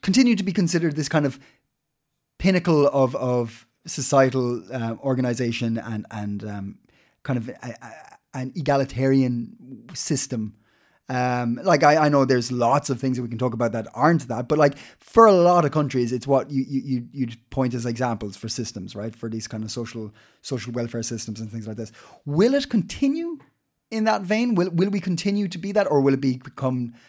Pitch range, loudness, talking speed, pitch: 115-155 Hz, -23 LUFS, 195 wpm, 130 Hz